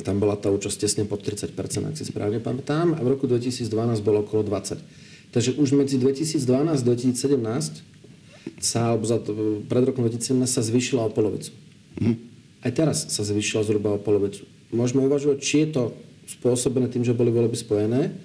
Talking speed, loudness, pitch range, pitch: 175 wpm, -24 LUFS, 110-140 Hz, 120 Hz